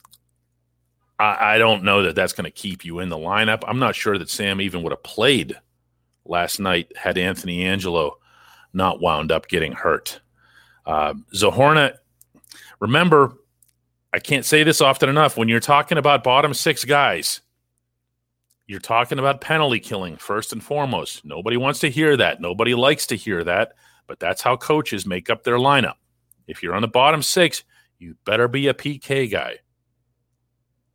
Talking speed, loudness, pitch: 165 wpm, -19 LUFS, 115 Hz